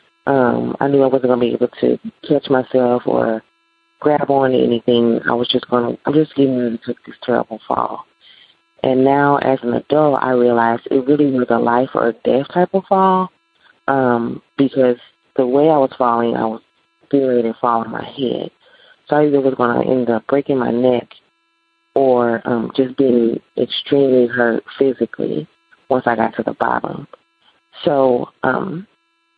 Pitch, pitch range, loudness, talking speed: 130 Hz, 120-150 Hz, -17 LUFS, 180 wpm